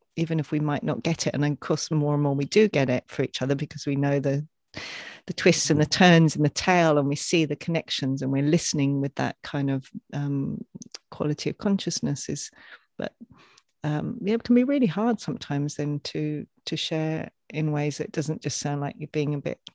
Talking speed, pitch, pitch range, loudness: 220 wpm, 150 Hz, 145-165 Hz, -25 LUFS